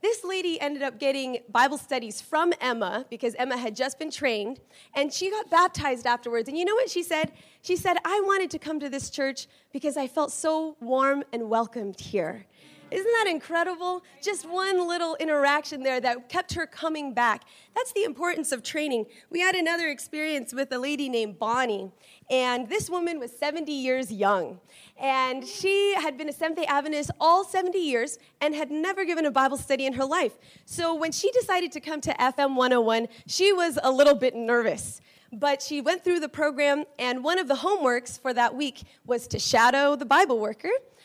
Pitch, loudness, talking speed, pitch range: 295 Hz, -26 LUFS, 195 wpm, 255-345 Hz